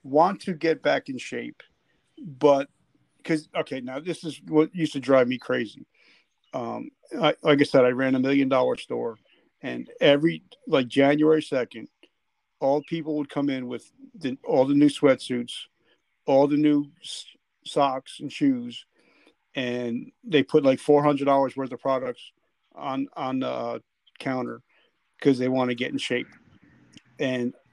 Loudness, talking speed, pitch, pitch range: -24 LUFS, 160 wpm, 140 Hz, 130-155 Hz